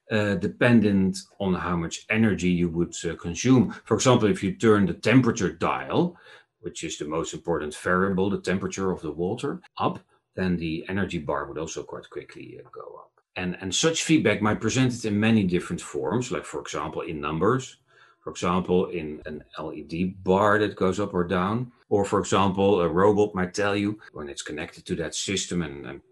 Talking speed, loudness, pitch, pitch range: 195 wpm, -25 LUFS, 95 Hz, 90-110 Hz